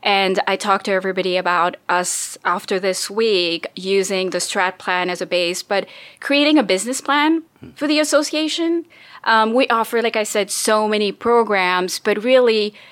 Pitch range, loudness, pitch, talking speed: 185-250 Hz, -18 LUFS, 205 Hz, 165 wpm